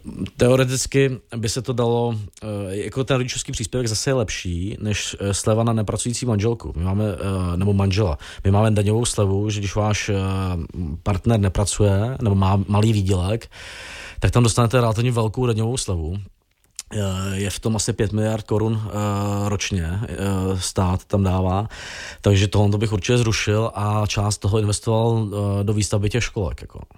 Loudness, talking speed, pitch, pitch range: -21 LUFS, 150 wpm, 105 Hz, 100-115 Hz